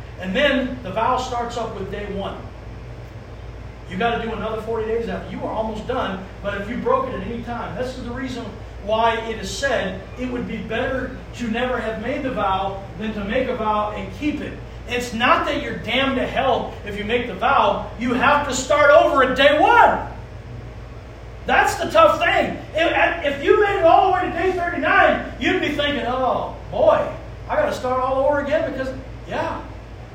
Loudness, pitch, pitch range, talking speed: -20 LUFS, 250 Hz, 220-295 Hz, 205 wpm